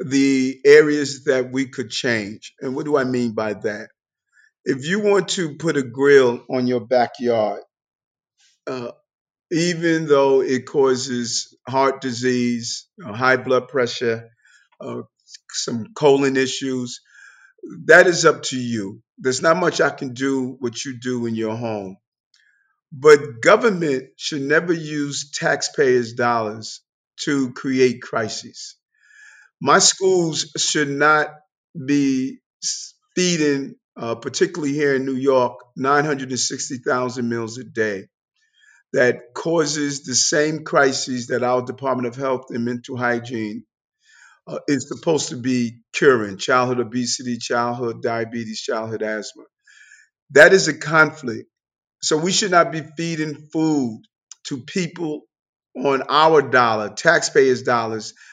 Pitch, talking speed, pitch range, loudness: 135 Hz, 125 wpm, 120-155 Hz, -19 LUFS